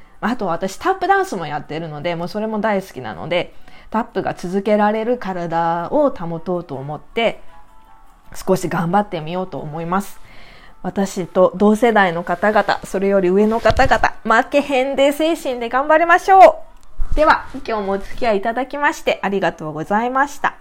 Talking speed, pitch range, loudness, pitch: 345 characters per minute, 175-250 Hz, -17 LUFS, 200 Hz